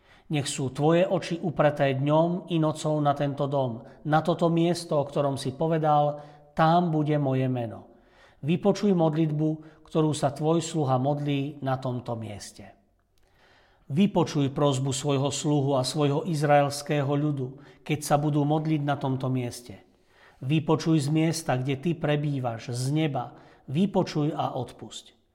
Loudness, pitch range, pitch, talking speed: -26 LUFS, 130-155 Hz, 145 Hz, 135 wpm